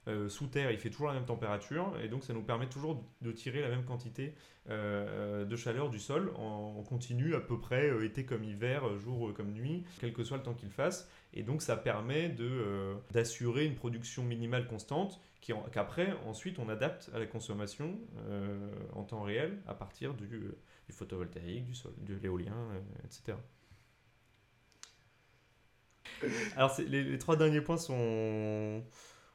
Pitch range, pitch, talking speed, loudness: 110-135 Hz, 115 Hz, 185 wpm, -38 LUFS